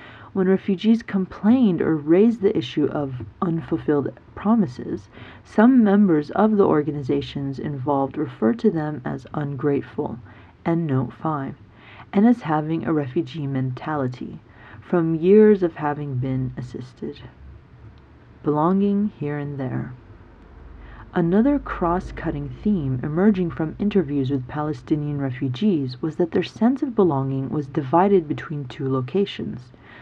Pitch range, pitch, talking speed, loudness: 130-185 Hz, 150 Hz, 120 wpm, -22 LUFS